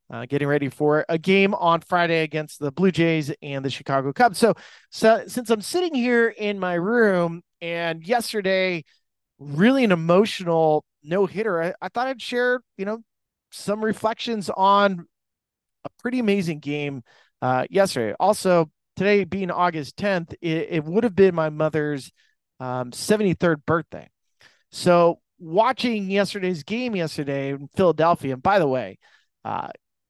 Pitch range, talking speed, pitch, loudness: 155-210 Hz, 150 wpm, 180 Hz, -22 LUFS